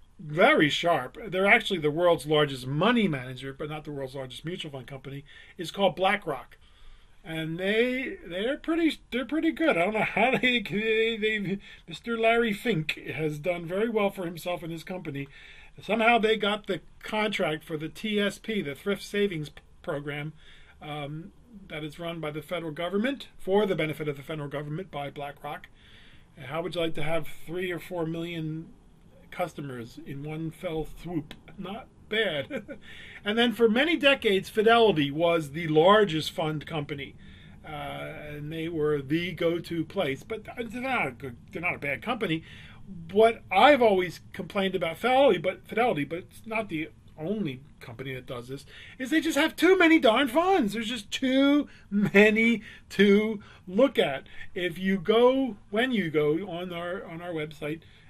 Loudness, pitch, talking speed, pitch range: -27 LUFS, 175 Hz, 170 wpm, 155-220 Hz